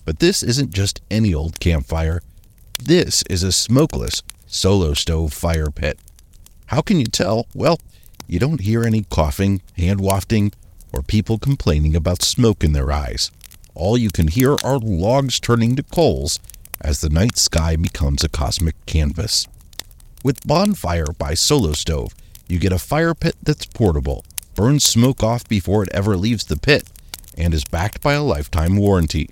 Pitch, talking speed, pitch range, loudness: 95 Hz, 165 wpm, 80-115 Hz, -18 LUFS